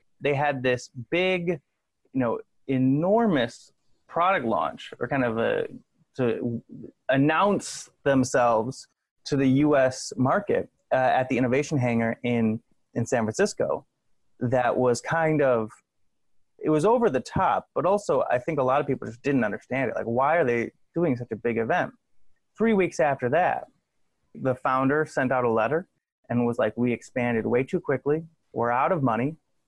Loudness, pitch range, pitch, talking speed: -25 LUFS, 120-155 Hz, 130 Hz, 165 wpm